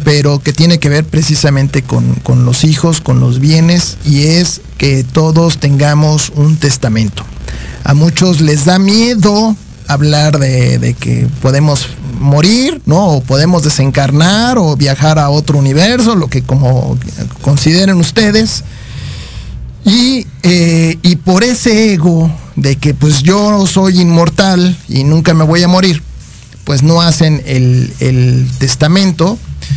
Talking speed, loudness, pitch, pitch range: 140 wpm, -9 LUFS, 150 Hz, 135-175 Hz